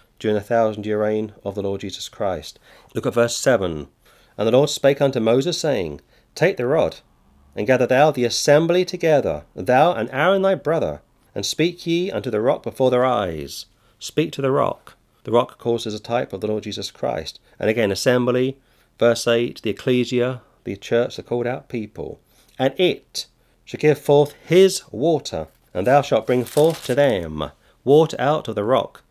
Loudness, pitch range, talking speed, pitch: -20 LUFS, 110-145 Hz, 185 wpm, 125 Hz